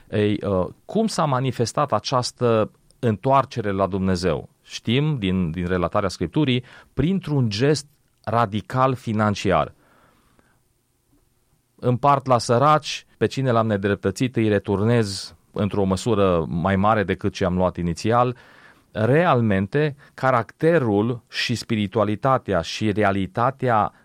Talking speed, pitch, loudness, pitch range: 100 wpm, 115 Hz, -22 LUFS, 100-130 Hz